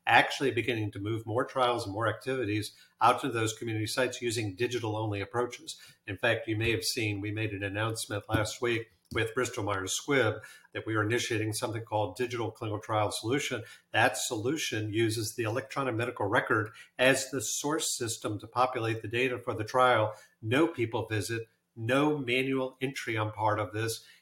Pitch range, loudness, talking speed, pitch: 110-125 Hz, -30 LUFS, 180 wpm, 115 Hz